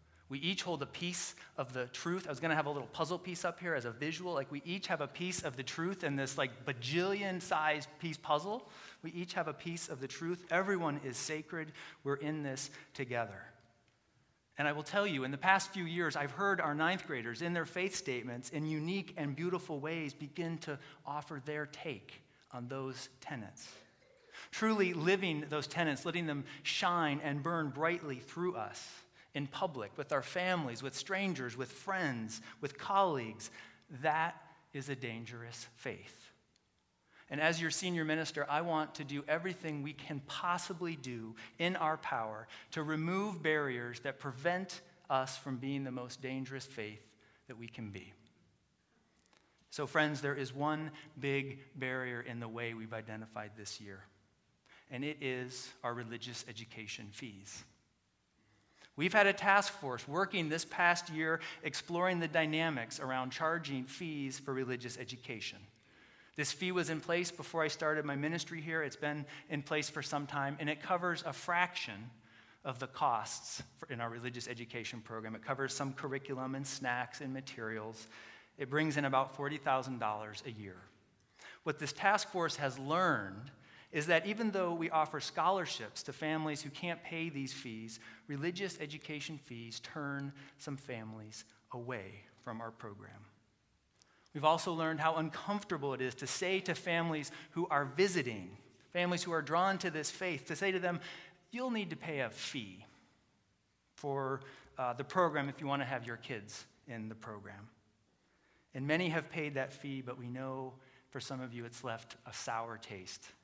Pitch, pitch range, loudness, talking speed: 145 Hz, 125-165 Hz, -38 LUFS, 170 wpm